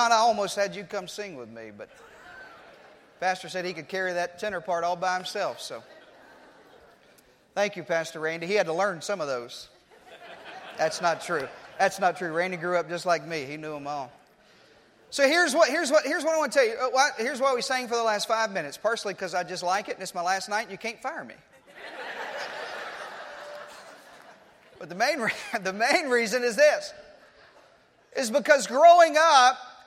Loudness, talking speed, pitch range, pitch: -25 LUFS, 195 wpm, 180-255 Hz, 205 Hz